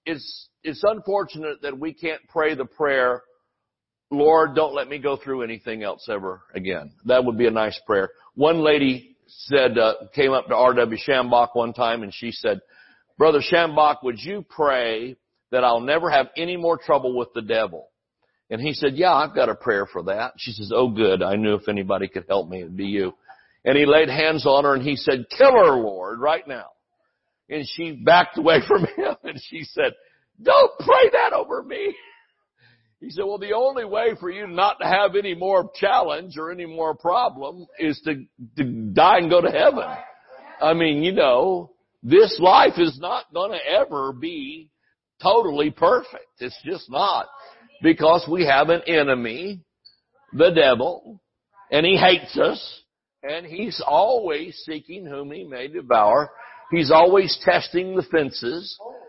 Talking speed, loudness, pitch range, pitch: 175 wpm, -20 LUFS, 125-195 Hz, 160 Hz